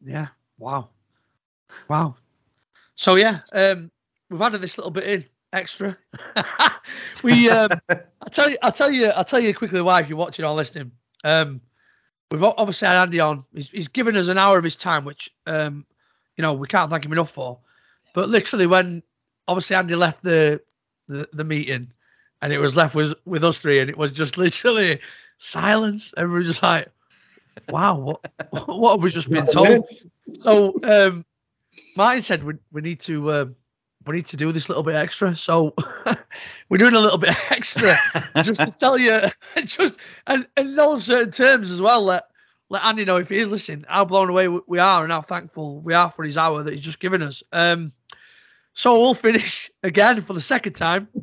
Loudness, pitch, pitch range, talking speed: -19 LUFS, 175 Hz, 155-205 Hz, 190 wpm